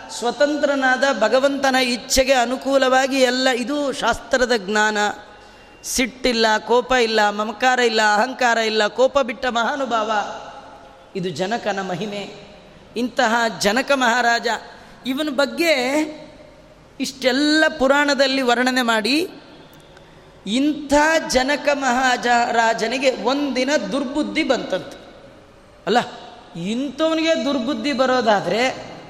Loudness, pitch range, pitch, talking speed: -19 LUFS, 230-280 Hz, 255 Hz, 85 wpm